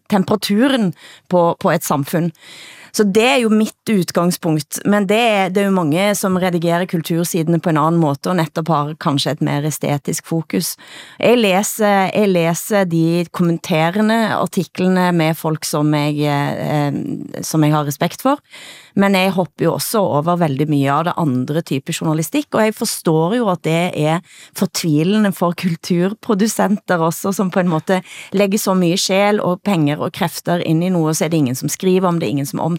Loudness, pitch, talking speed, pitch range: -17 LUFS, 175 Hz, 180 wpm, 160-200 Hz